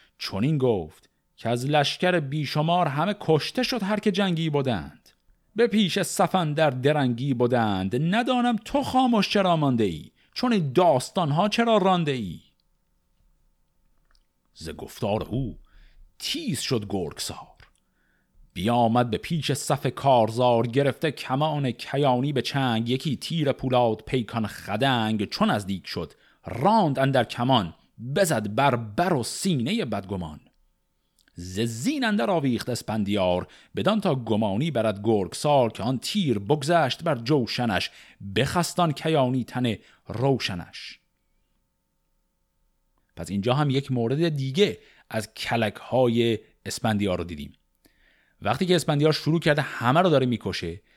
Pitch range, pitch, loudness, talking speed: 110-160 Hz, 130 Hz, -24 LUFS, 125 wpm